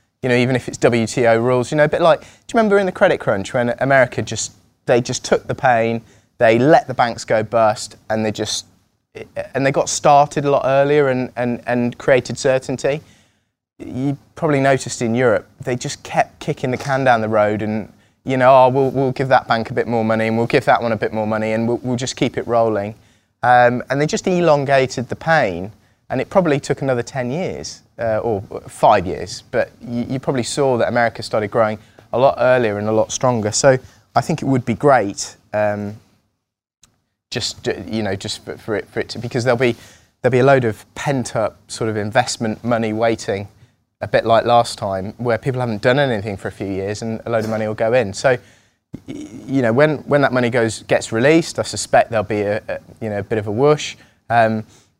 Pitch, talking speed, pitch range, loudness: 120 Hz, 220 wpm, 110-130 Hz, -18 LUFS